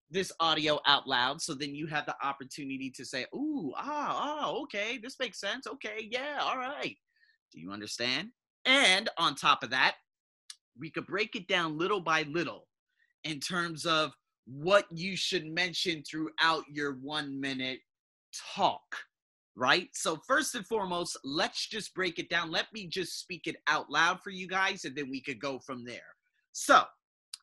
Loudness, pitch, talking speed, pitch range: -31 LUFS, 170 Hz, 175 wpm, 145-220 Hz